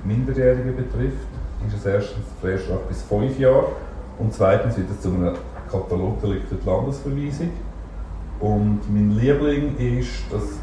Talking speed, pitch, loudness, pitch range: 135 wpm, 105 Hz, -22 LUFS, 95-125 Hz